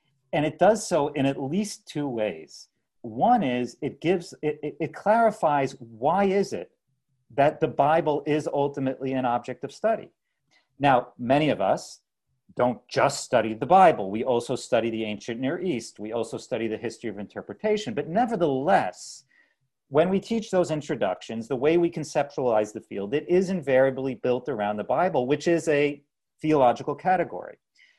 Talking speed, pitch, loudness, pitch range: 165 wpm, 145 Hz, -25 LUFS, 125-170 Hz